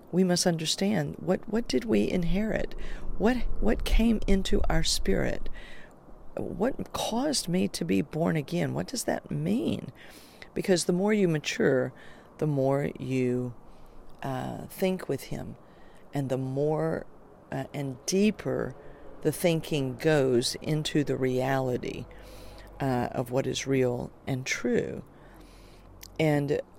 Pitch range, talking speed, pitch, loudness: 130-185 Hz, 130 wpm, 155 Hz, -29 LUFS